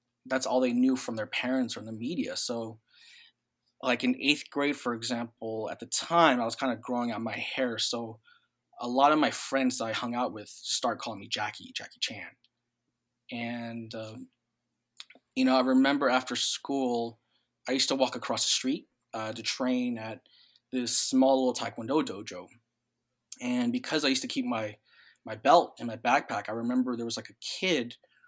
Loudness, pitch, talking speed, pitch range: -29 LUFS, 120 Hz, 190 wpm, 115-130 Hz